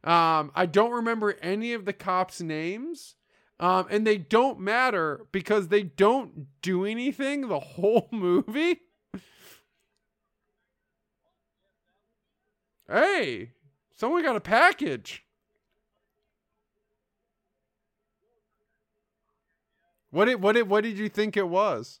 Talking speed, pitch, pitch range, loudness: 100 wpm, 215 Hz, 185-235 Hz, -25 LUFS